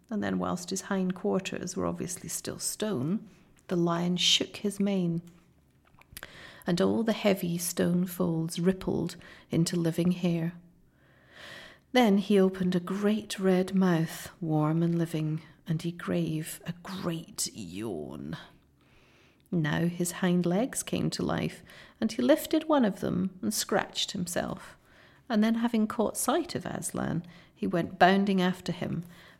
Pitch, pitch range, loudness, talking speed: 180 Hz, 170-200 Hz, -29 LUFS, 140 wpm